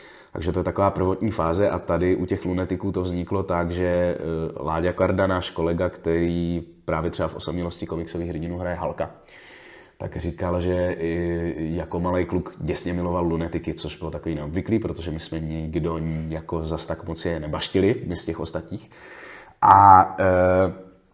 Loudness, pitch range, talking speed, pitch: -23 LUFS, 80-90 Hz, 160 wpm, 85 Hz